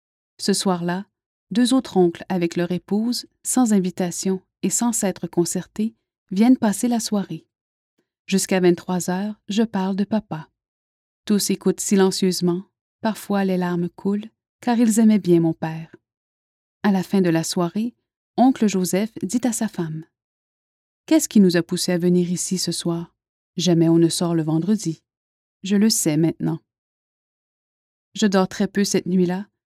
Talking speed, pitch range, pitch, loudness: 155 wpm, 170-210 Hz, 185 Hz, -21 LUFS